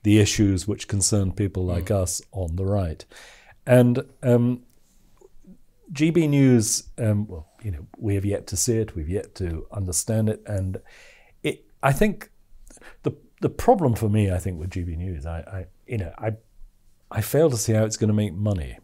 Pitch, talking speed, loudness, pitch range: 105 Hz, 185 wpm, -23 LUFS, 95-115 Hz